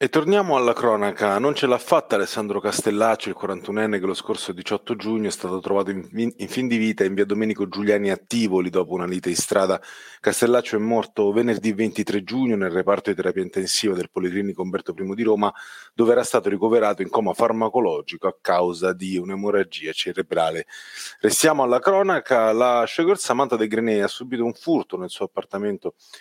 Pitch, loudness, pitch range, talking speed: 110 Hz, -22 LUFS, 100-120 Hz, 185 wpm